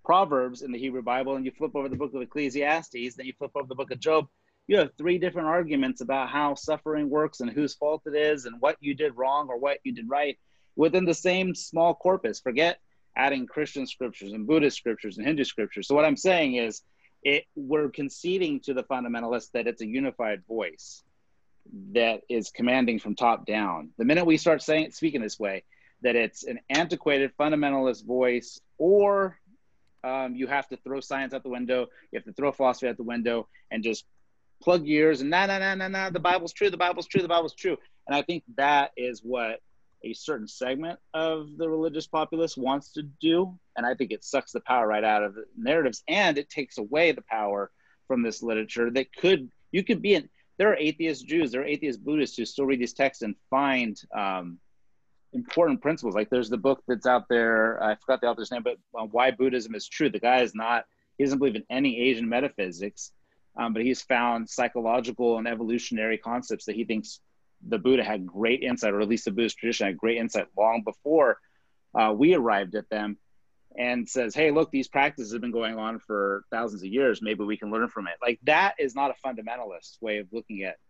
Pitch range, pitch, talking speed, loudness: 115-155 Hz, 130 Hz, 210 wpm, -27 LUFS